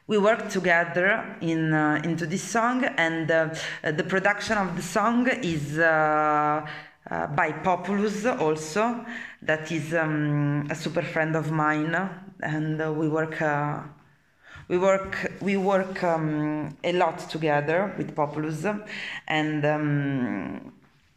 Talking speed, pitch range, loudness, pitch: 135 wpm, 155-190 Hz, -25 LUFS, 165 Hz